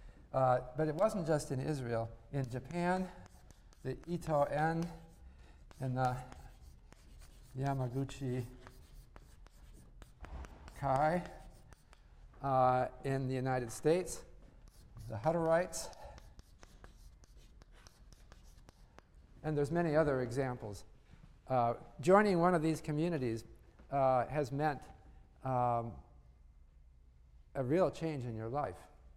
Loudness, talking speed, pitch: -35 LUFS, 90 wpm, 125 Hz